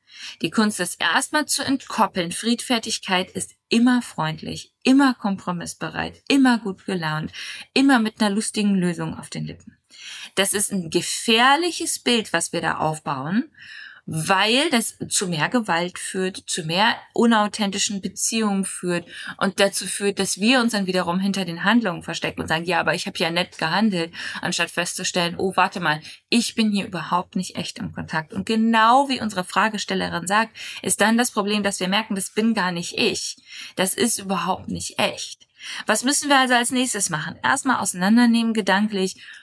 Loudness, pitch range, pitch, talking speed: -21 LUFS, 180-230 Hz, 200 Hz, 165 wpm